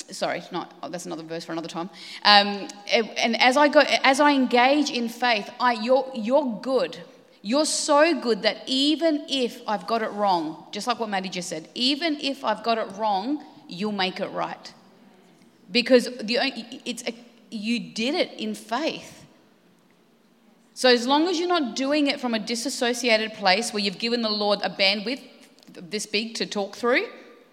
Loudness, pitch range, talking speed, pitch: -23 LUFS, 205-265 Hz, 180 wpm, 235 Hz